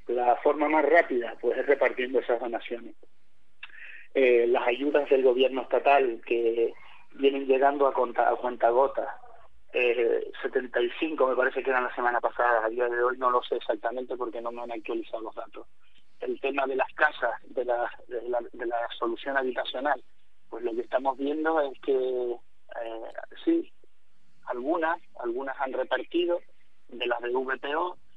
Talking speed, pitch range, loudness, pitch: 165 wpm, 120-155 Hz, -27 LUFS, 130 Hz